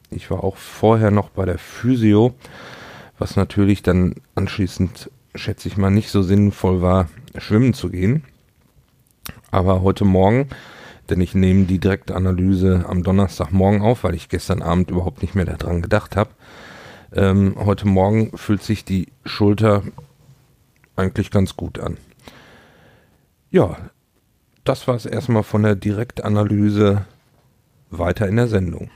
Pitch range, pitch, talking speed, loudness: 95-110 Hz, 100 Hz, 135 wpm, -19 LUFS